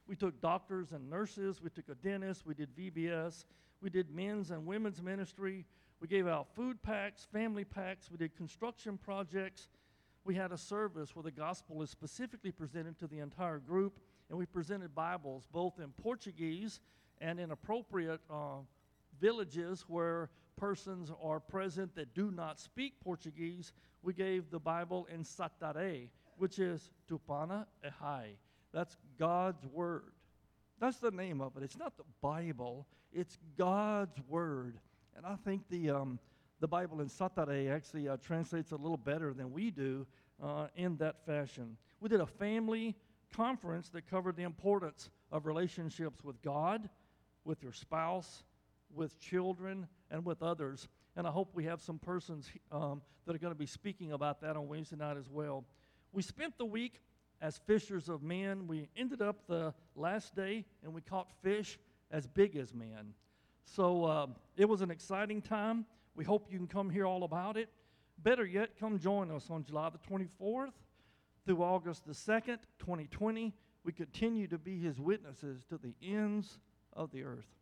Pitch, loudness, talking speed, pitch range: 170 Hz, -40 LUFS, 170 wpm, 155-195 Hz